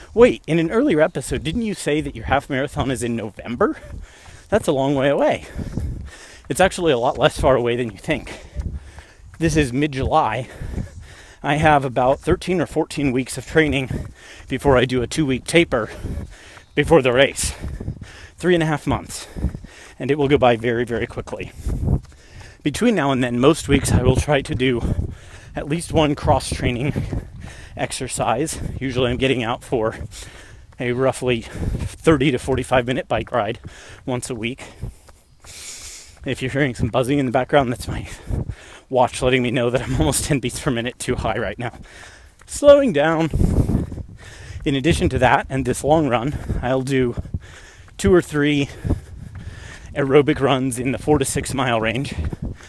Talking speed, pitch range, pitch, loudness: 170 wpm, 105-145 Hz, 130 Hz, -20 LUFS